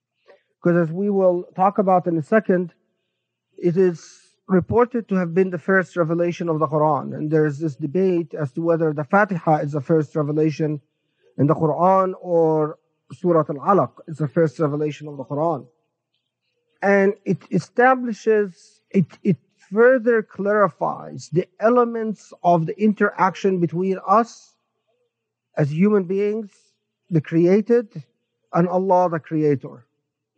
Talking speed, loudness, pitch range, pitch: 140 wpm, -20 LUFS, 155-195 Hz, 175 Hz